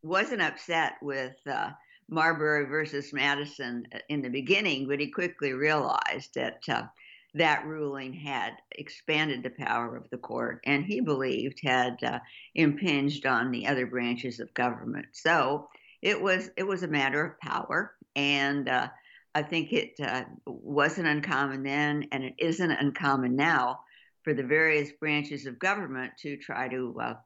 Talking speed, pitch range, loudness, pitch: 155 wpm, 135-155 Hz, -29 LUFS, 145 Hz